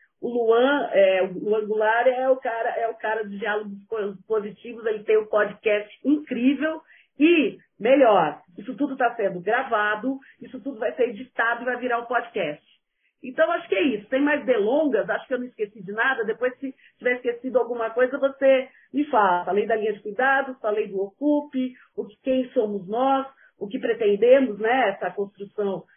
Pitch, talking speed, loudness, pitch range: 240 Hz, 185 wpm, -23 LUFS, 215-270 Hz